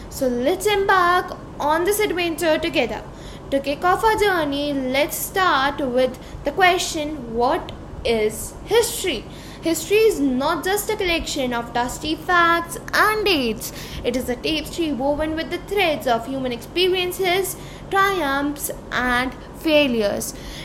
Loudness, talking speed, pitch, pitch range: -21 LUFS, 130 wpm, 315 Hz, 270-365 Hz